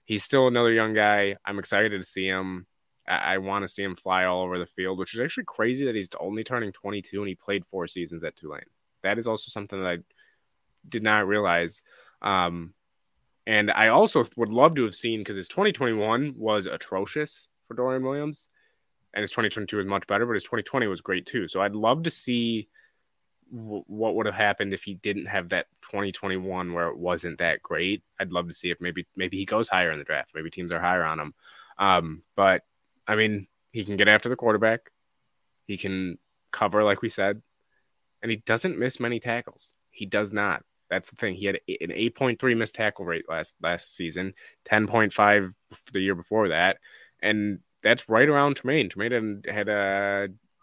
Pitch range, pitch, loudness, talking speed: 95-115 Hz, 105 Hz, -26 LUFS, 195 wpm